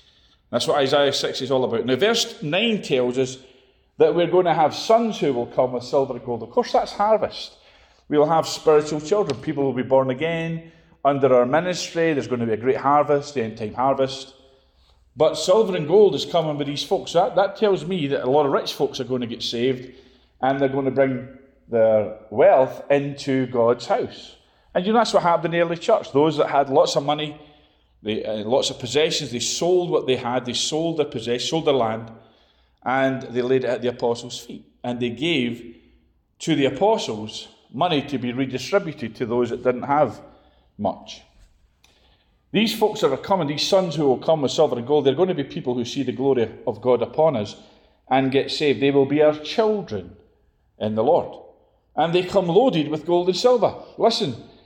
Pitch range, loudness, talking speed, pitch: 125-160 Hz, -21 LUFS, 210 wpm, 135 Hz